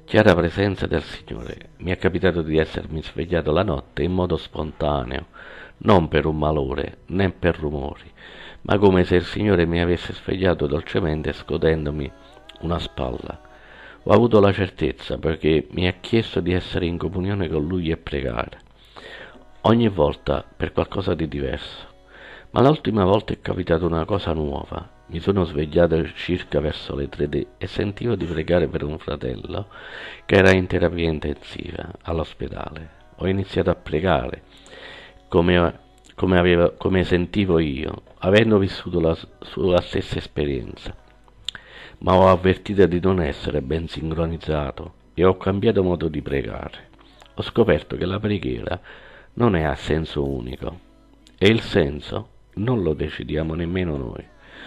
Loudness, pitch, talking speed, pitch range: -22 LUFS, 85 Hz, 145 wpm, 80-95 Hz